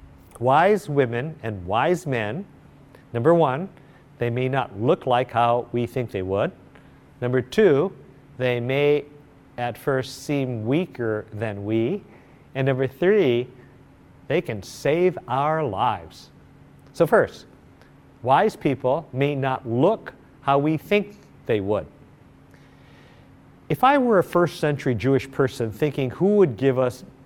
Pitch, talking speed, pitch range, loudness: 135 Hz, 130 wpm, 120-145 Hz, -23 LUFS